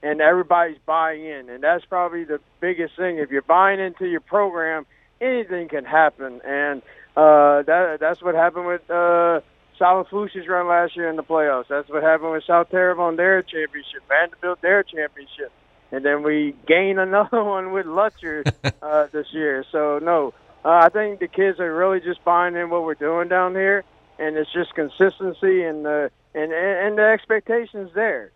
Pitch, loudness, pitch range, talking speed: 170 Hz, -20 LUFS, 155-185 Hz, 175 wpm